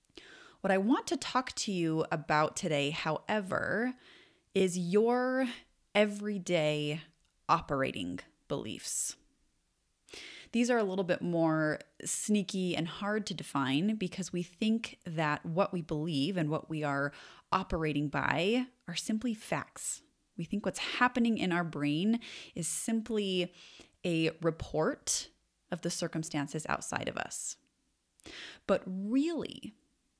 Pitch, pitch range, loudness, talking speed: 180 Hz, 160-220 Hz, -33 LUFS, 120 wpm